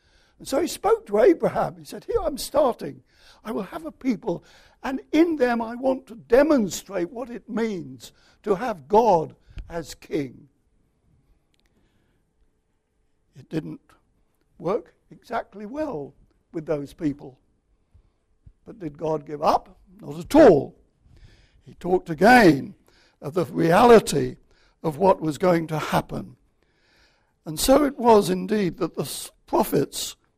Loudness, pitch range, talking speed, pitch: -22 LUFS, 160-255 Hz, 130 wpm, 195 Hz